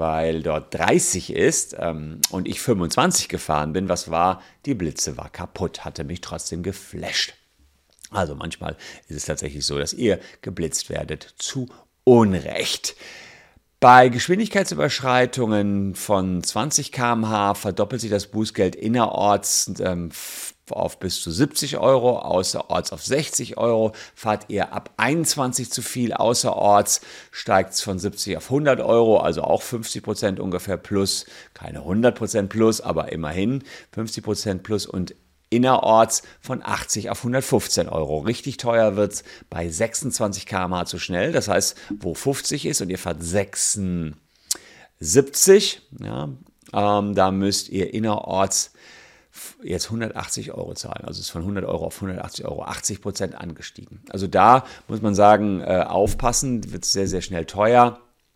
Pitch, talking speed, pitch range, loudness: 100 Hz, 140 wpm, 90-120 Hz, -21 LUFS